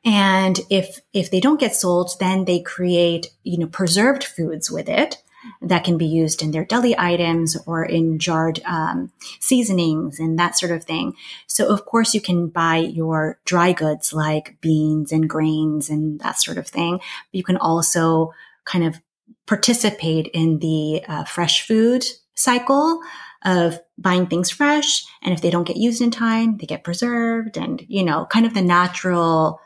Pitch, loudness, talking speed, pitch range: 175 Hz, -19 LUFS, 175 wpm, 160-215 Hz